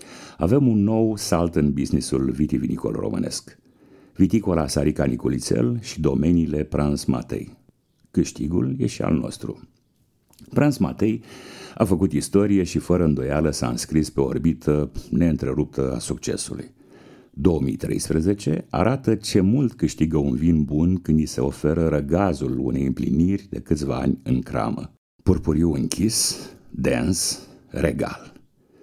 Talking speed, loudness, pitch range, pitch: 125 wpm, -22 LUFS, 70-95 Hz, 80 Hz